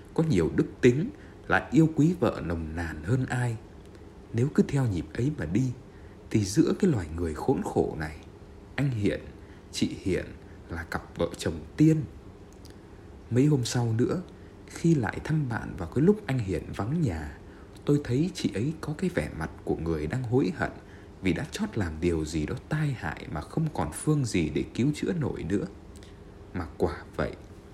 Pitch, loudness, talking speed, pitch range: 100 Hz, -28 LUFS, 185 wpm, 85-135 Hz